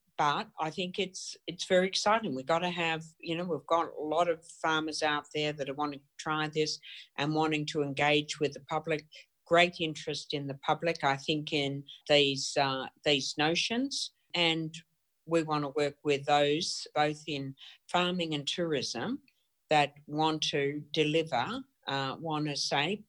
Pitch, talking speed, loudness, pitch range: 155 Hz, 170 wpm, -31 LUFS, 145-165 Hz